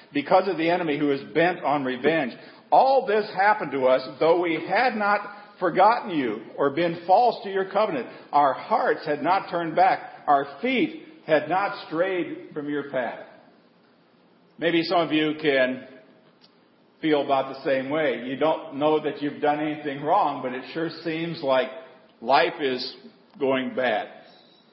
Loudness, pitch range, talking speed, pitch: -24 LUFS, 145-205 Hz, 165 wpm, 165 Hz